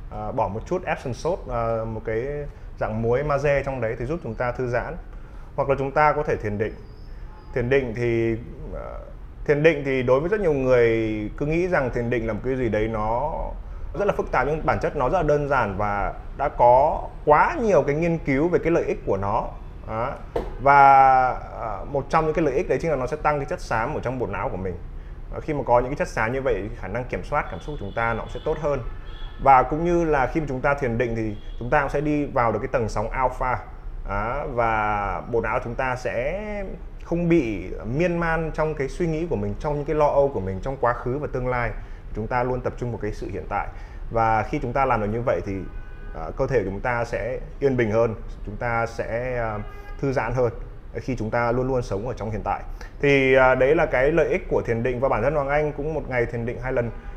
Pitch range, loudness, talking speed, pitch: 110-145 Hz, -23 LUFS, 255 wpm, 125 Hz